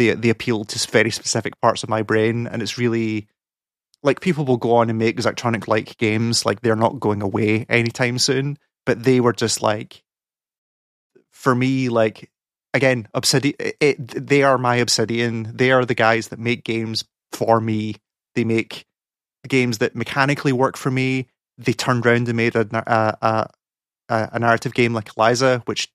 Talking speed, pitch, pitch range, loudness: 175 wpm, 120 Hz, 110-130 Hz, -20 LUFS